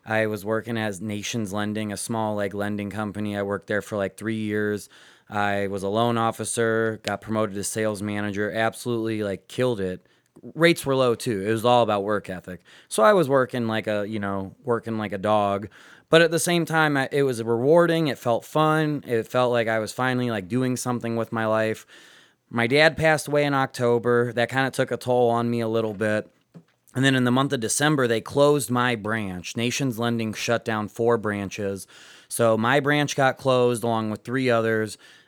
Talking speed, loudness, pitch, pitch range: 205 wpm, -23 LUFS, 115 Hz, 105-125 Hz